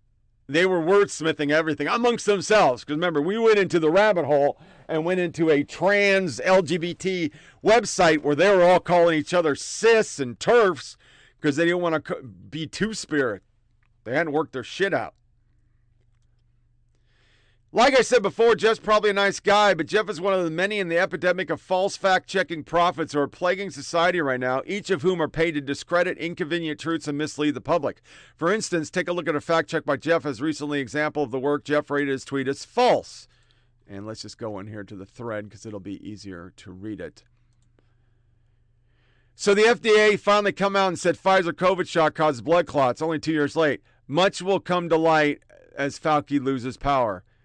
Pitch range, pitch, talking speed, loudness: 125-180 Hz, 155 Hz, 195 wpm, -22 LUFS